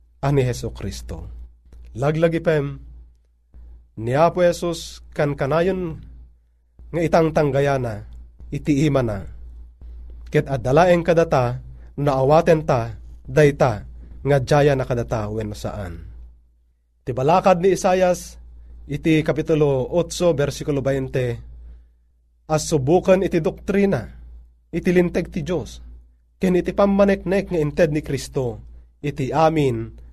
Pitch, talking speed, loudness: 135 Hz, 105 wpm, -20 LUFS